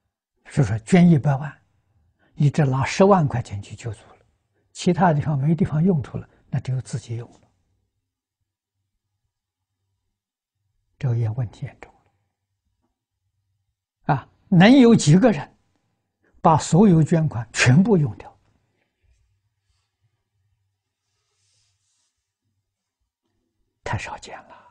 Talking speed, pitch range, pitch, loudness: 150 characters per minute, 100-140 Hz, 105 Hz, -19 LUFS